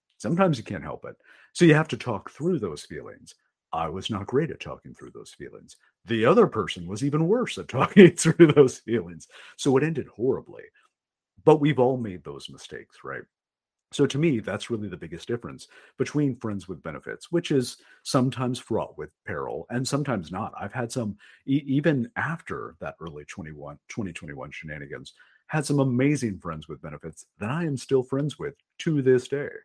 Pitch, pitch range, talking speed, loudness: 130 Hz, 110-150 Hz, 180 wpm, -25 LUFS